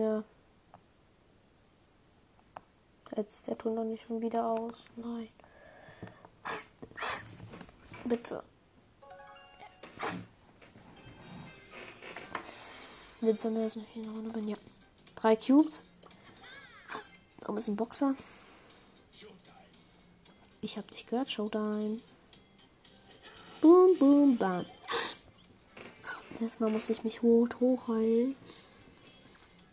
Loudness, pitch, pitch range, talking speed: -31 LUFS, 225 Hz, 220-235 Hz, 80 wpm